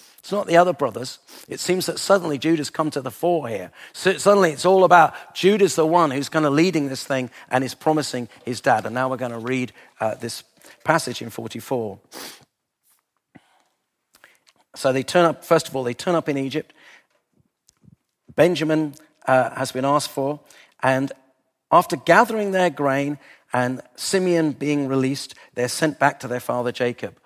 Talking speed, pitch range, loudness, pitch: 175 wpm, 130-170 Hz, -21 LUFS, 145 Hz